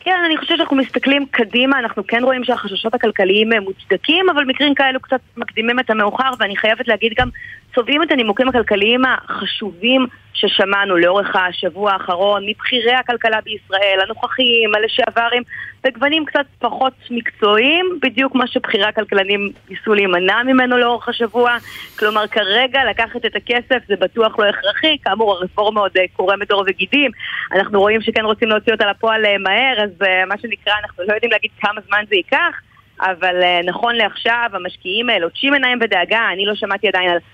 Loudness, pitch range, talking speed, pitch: -15 LUFS, 205-255 Hz, 155 wpm, 225 Hz